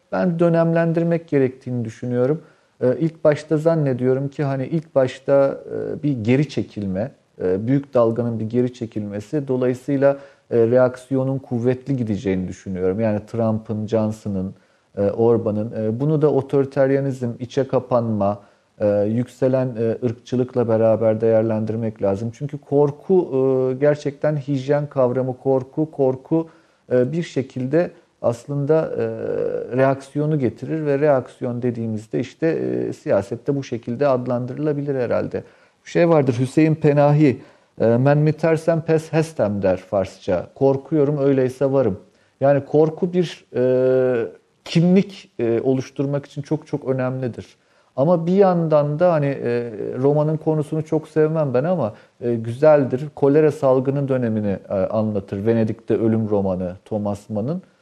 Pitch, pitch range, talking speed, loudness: 130 Hz, 115-150 Hz, 115 wpm, -20 LUFS